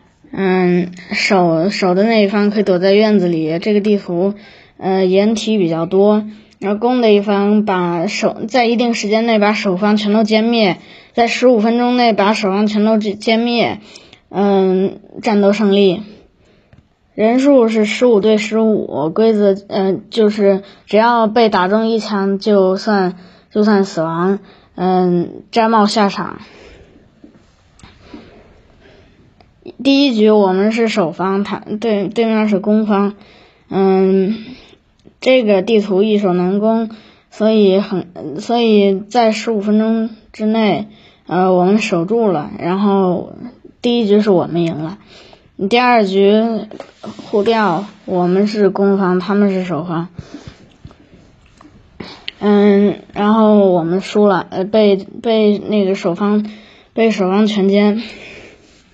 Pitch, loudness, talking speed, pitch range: 205 Hz, -14 LUFS, 185 characters per minute, 190-220 Hz